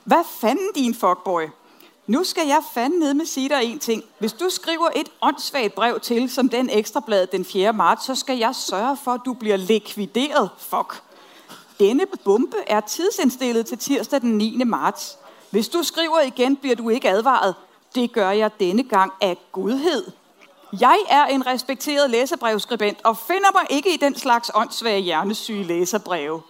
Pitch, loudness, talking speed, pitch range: 245 Hz, -20 LUFS, 175 wpm, 210-290 Hz